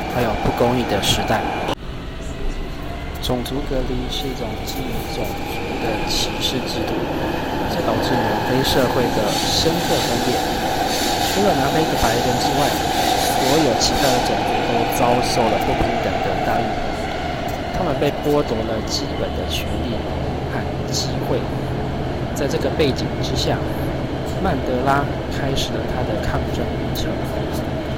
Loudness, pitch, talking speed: -20 LUFS, 105 Hz, 205 characters per minute